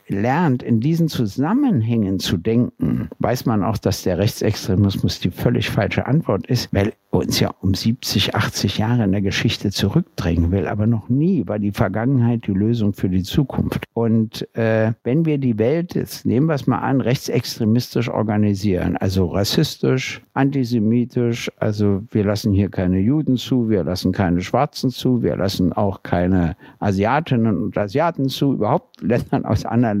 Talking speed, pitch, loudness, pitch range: 165 wpm, 110 Hz, -19 LUFS, 100-125 Hz